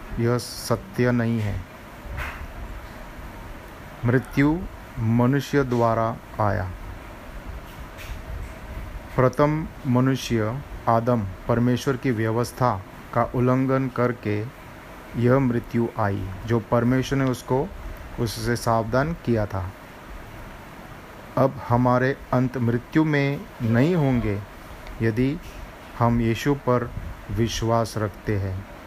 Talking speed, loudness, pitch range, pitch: 85 wpm, -24 LUFS, 105-130 Hz, 120 Hz